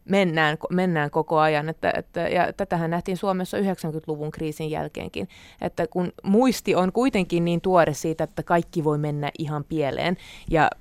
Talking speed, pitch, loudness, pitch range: 155 wpm, 165 Hz, -24 LUFS, 155-185 Hz